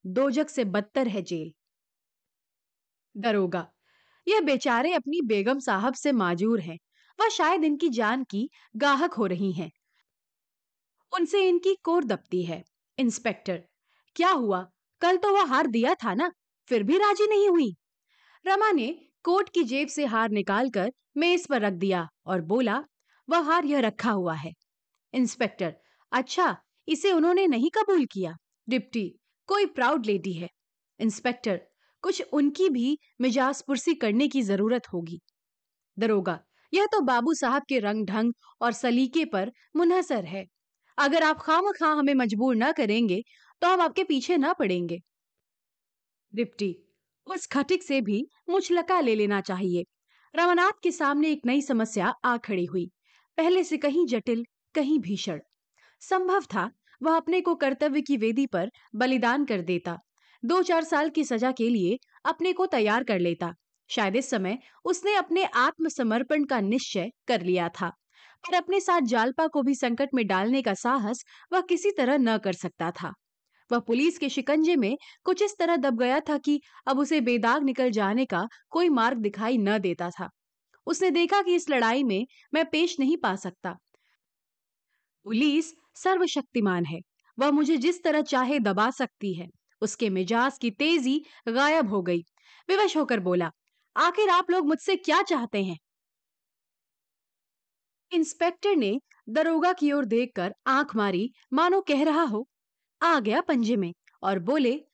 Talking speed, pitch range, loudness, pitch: 155 wpm, 200-325 Hz, -26 LUFS, 255 Hz